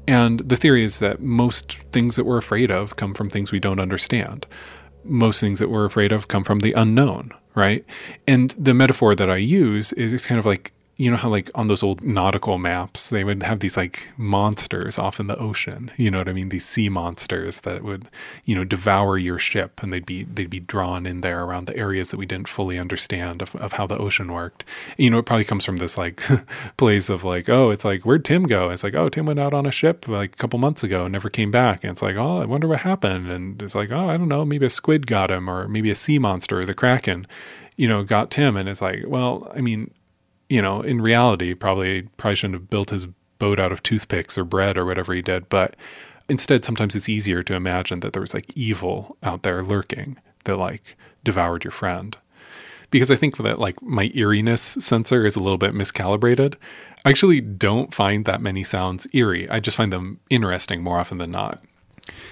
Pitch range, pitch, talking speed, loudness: 95-120 Hz, 105 Hz, 230 wpm, -20 LUFS